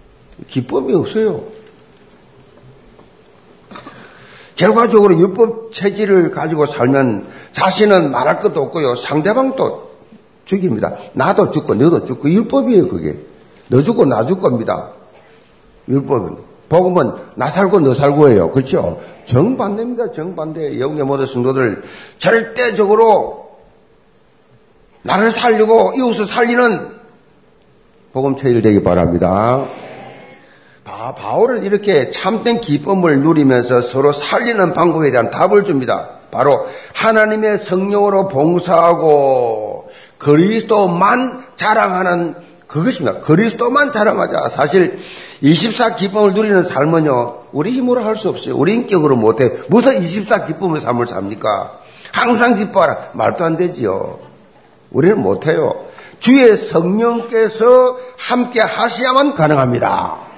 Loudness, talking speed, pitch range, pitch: -14 LUFS, 260 characters per minute, 150-230 Hz, 200 Hz